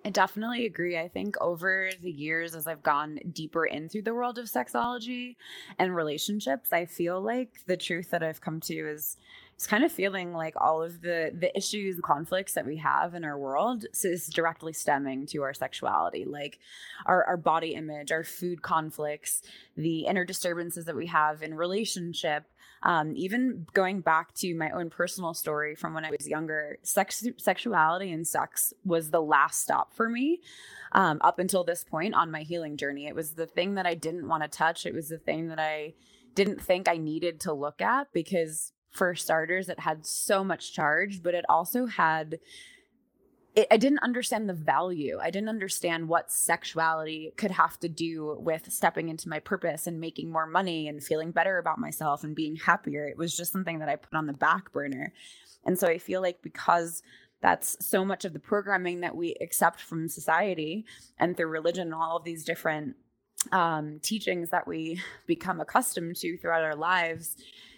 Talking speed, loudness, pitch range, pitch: 190 wpm, -29 LUFS, 160-190 Hz, 170 Hz